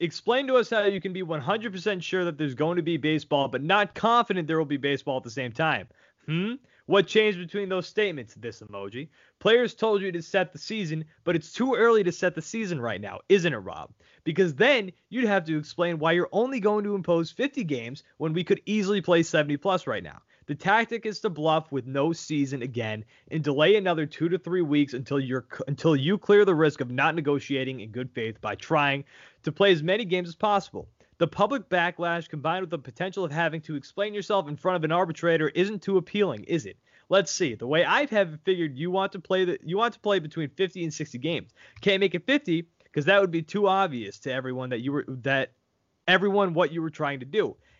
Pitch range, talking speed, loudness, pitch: 145-200 Hz, 225 wpm, -26 LUFS, 170 Hz